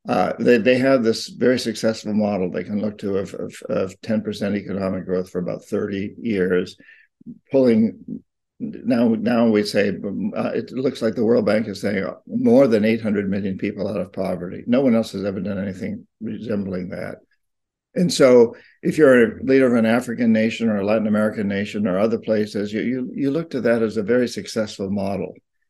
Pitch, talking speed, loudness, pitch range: 110 Hz, 190 wpm, -20 LUFS, 100-125 Hz